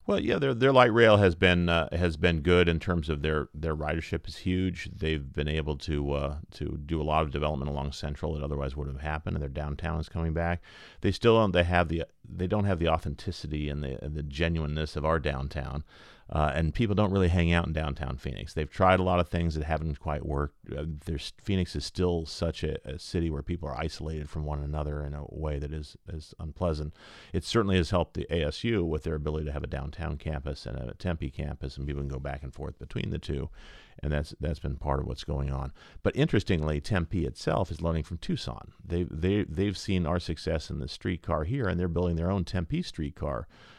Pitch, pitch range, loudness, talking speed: 80 Hz, 75-90 Hz, -30 LUFS, 230 wpm